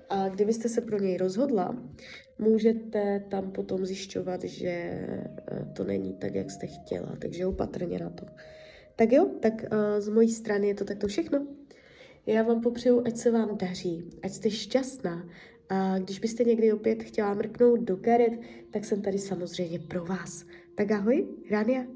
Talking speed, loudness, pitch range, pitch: 160 wpm, -29 LUFS, 185-230 Hz, 210 Hz